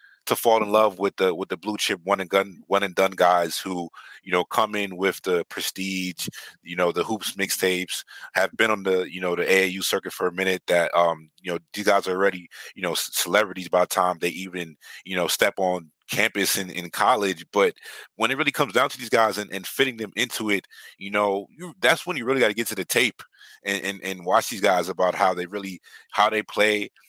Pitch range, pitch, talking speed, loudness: 90-105 Hz, 95 Hz, 240 wpm, -23 LUFS